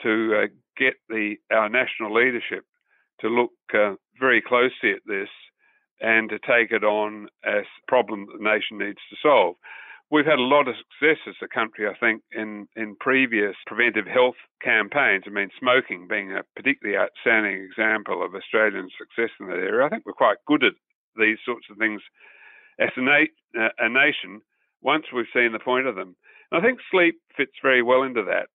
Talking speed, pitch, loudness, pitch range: 185 wpm, 120 Hz, -22 LUFS, 110-135 Hz